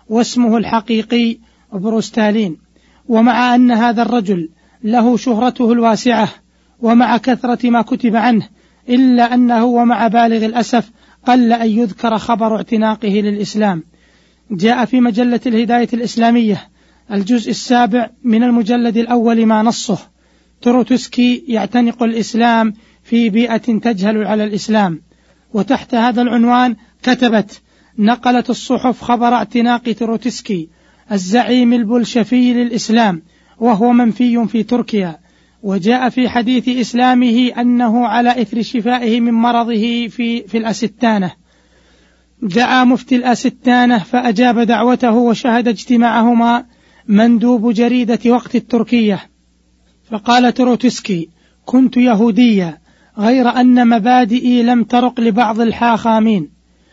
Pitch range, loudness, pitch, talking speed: 220-245 Hz, -13 LUFS, 235 Hz, 100 wpm